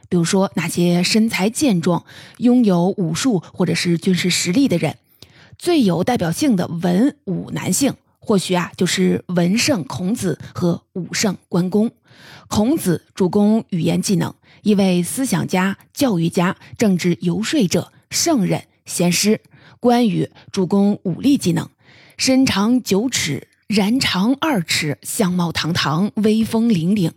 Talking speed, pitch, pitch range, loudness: 210 characters per minute, 185 Hz, 175-220 Hz, -18 LUFS